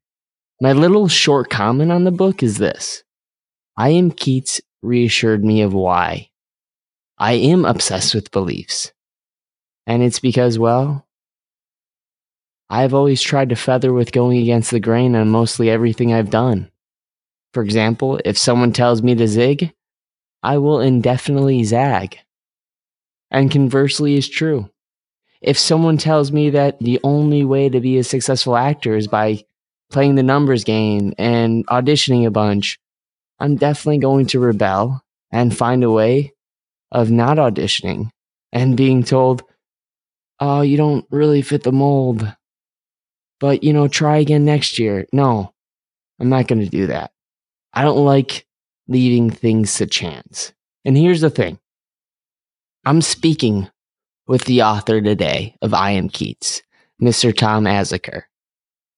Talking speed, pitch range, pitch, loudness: 140 wpm, 115-140 Hz, 125 Hz, -16 LUFS